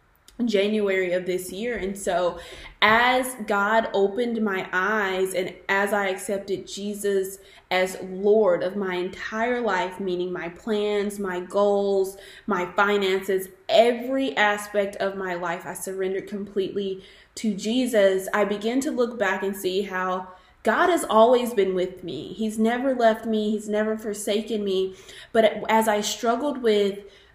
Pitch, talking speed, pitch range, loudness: 200 Hz, 145 wpm, 190-220 Hz, -24 LUFS